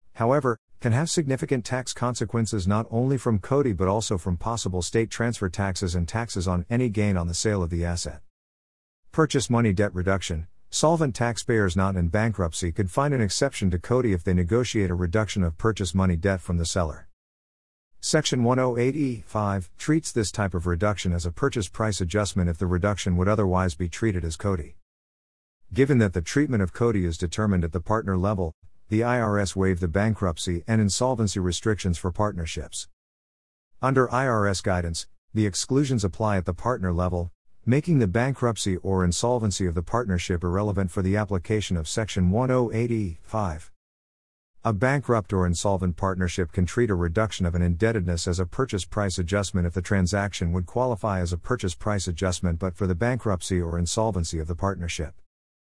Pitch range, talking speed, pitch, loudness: 90-115 Hz, 175 wpm, 100 Hz, -25 LUFS